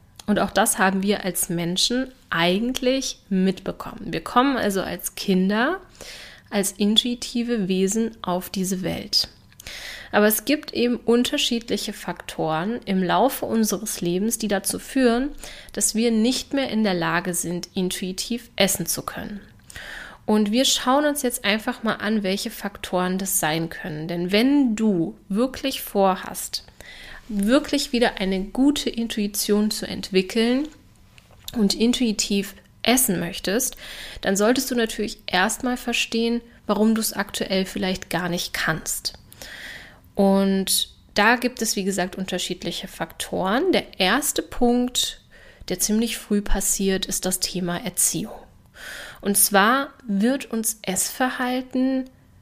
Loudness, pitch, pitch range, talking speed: -22 LUFS, 210 Hz, 190-240 Hz, 130 wpm